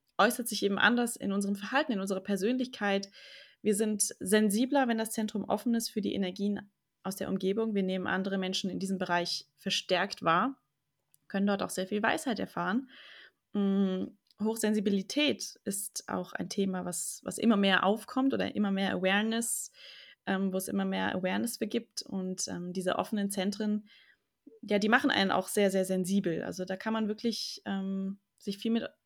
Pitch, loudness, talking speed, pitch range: 200 Hz, -31 LUFS, 175 wpm, 190-225 Hz